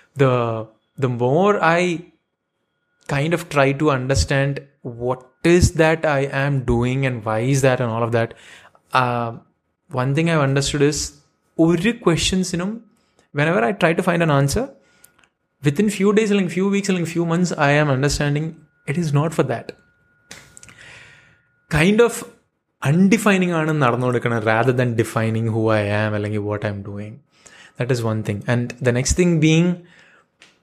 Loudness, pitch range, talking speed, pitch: -19 LUFS, 120-170 Hz, 155 wpm, 145 Hz